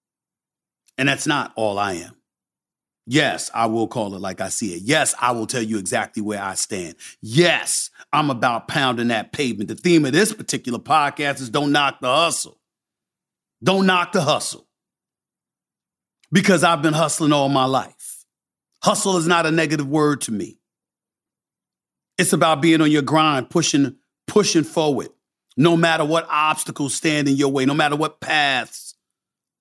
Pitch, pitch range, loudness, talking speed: 150 Hz, 130-165 Hz, -19 LUFS, 165 wpm